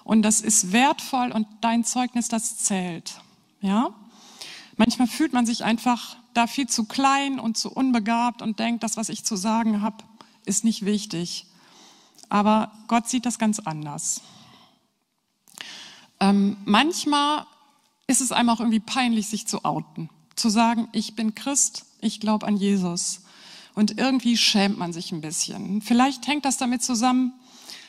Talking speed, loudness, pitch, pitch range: 155 wpm, -23 LUFS, 225 Hz, 210-250 Hz